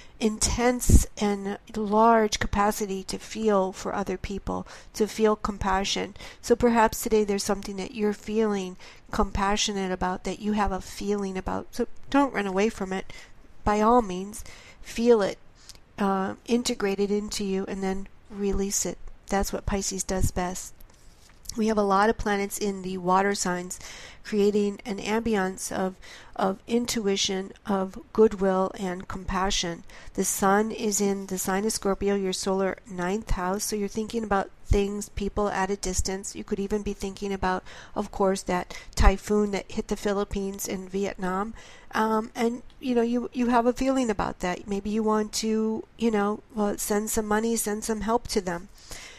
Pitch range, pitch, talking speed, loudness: 190-220 Hz, 205 Hz, 165 wpm, -27 LUFS